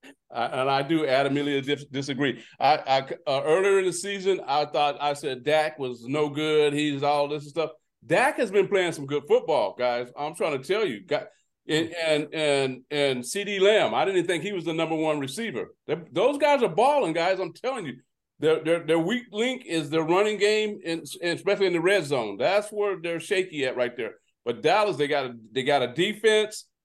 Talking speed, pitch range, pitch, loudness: 205 wpm, 145-200 Hz, 160 Hz, -25 LUFS